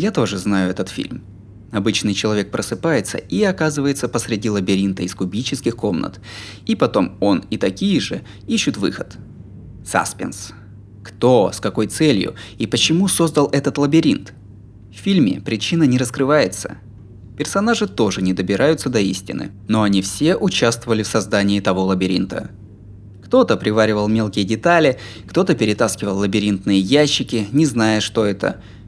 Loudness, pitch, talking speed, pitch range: -18 LUFS, 110 Hz, 135 wpm, 100-140 Hz